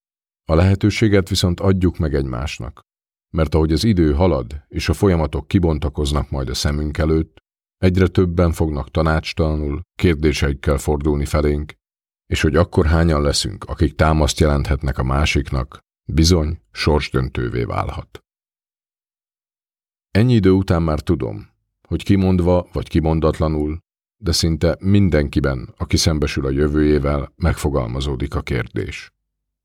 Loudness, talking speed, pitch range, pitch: -19 LUFS, 115 wpm, 75-90 Hz, 80 Hz